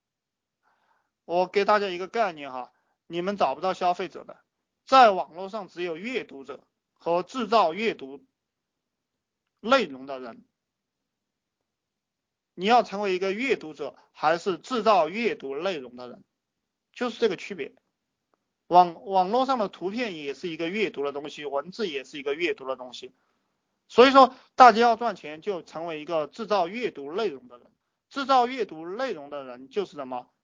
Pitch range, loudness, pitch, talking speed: 160-235 Hz, -25 LUFS, 190 Hz, 240 characters per minute